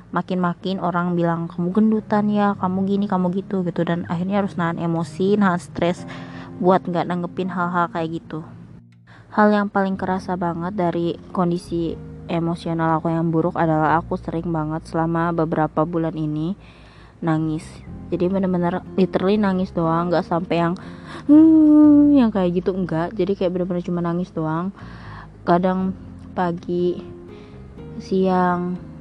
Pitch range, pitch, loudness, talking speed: 165-185 Hz, 175 Hz, -20 LUFS, 135 wpm